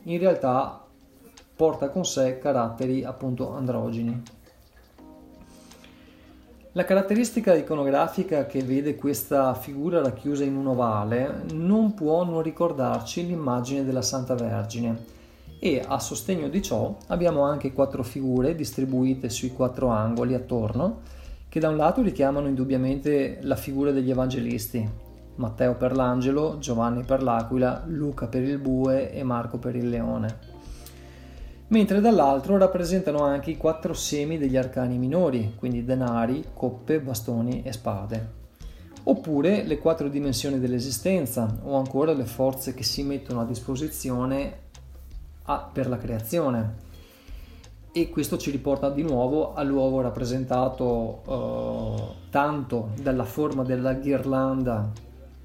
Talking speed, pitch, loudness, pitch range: 125 wpm, 130 Hz, -26 LUFS, 120-145 Hz